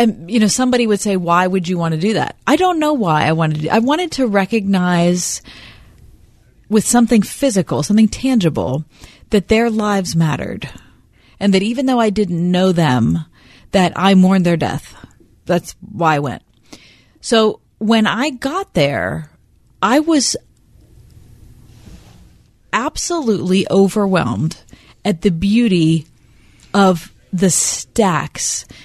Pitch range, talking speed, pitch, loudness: 150-220 Hz, 135 wpm, 185 Hz, -16 LUFS